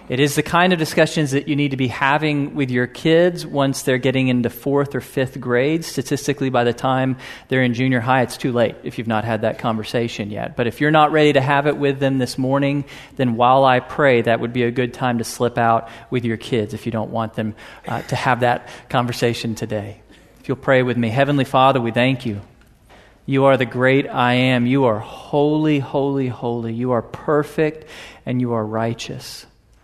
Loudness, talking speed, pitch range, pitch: -19 LUFS, 215 wpm, 120-140 Hz, 130 Hz